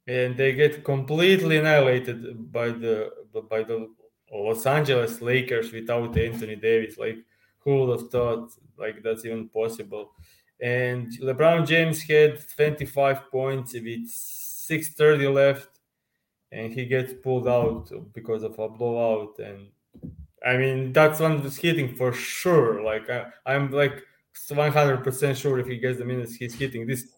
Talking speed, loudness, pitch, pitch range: 150 wpm, -24 LUFS, 125 Hz, 115-140 Hz